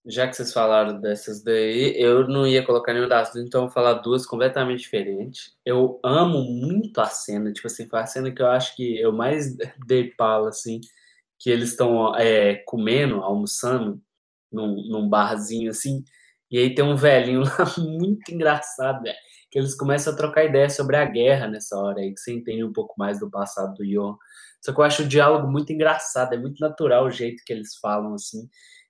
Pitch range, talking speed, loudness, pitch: 110-140 Hz, 200 wpm, -22 LUFS, 125 Hz